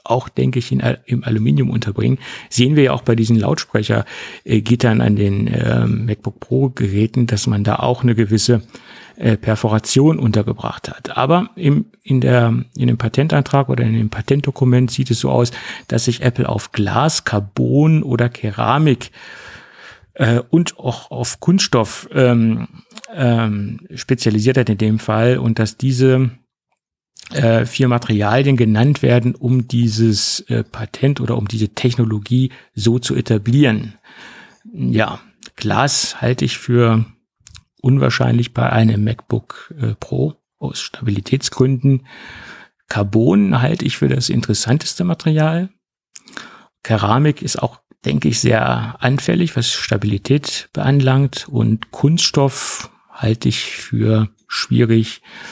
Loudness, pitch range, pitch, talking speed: -16 LUFS, 110-135 Hz, 120 Hz, 130 wpm